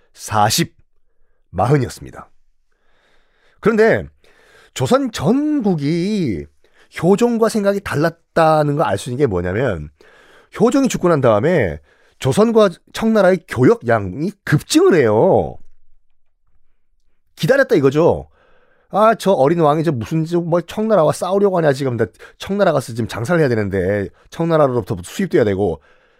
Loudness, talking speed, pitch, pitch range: -16 LUFS, 260 characters per minute, 175 Hz, 140-220 Hz